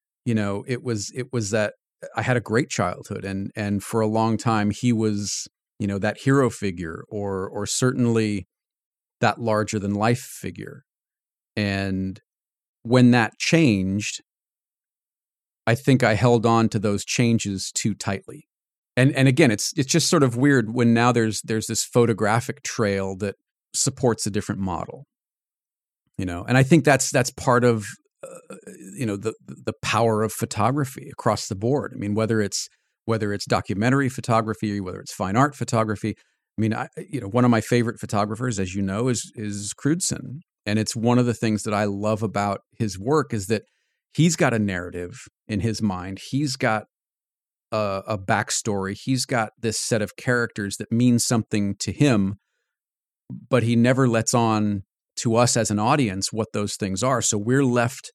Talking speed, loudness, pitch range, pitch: 175 wpm, -23 LUFS, 105-125 Hz, 110 Hz